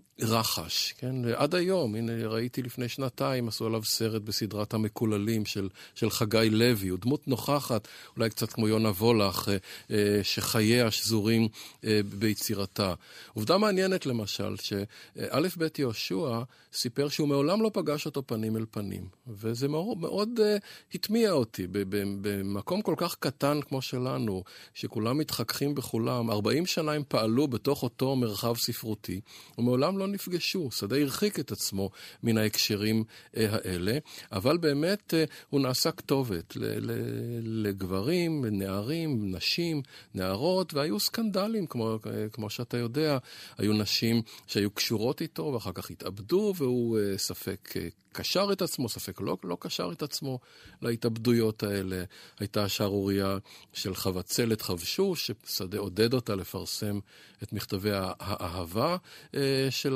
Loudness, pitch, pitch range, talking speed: -30 LUFS, 115 Hz, 105-140 Hz, 130 wpm